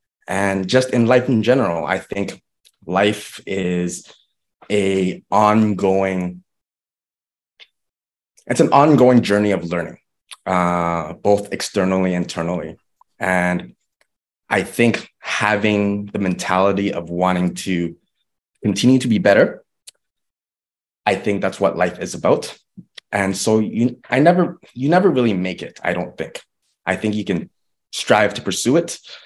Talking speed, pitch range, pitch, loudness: 130 wpm, 90-110 Hz, 100 Hz, -18 LUFS